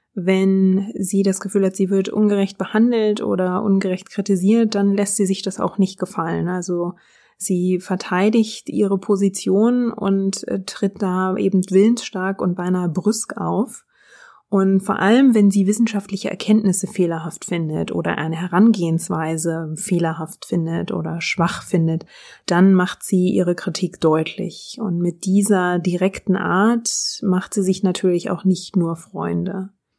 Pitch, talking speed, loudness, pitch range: 190 Hz, 140 wpm, -19 LUFS, 180-205 Hz